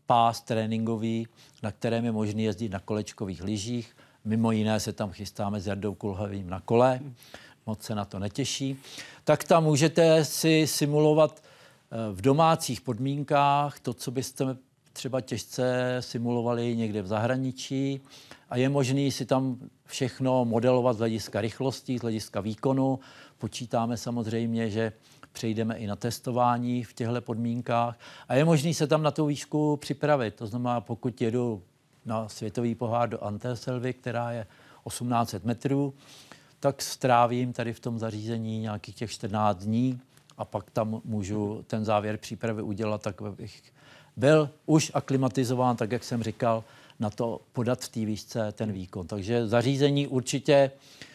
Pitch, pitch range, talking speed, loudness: 120 Hz, 110-135 Hz, 145 wpm, -28 LUFS